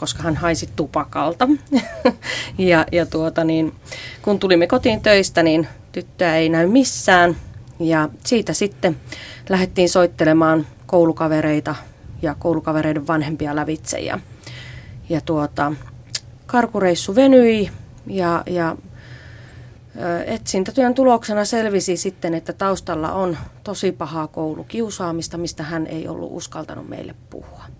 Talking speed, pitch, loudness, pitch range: 110 wpm, 165 Hz, -18 LUFS, 150-190 Hz